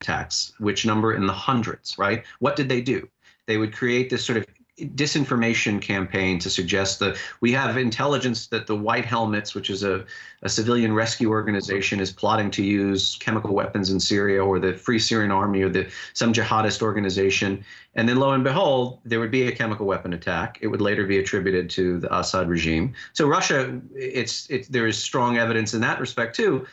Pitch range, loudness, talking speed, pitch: 95-120 Hz, -23 LUFS, 195 wpm, 110 Hz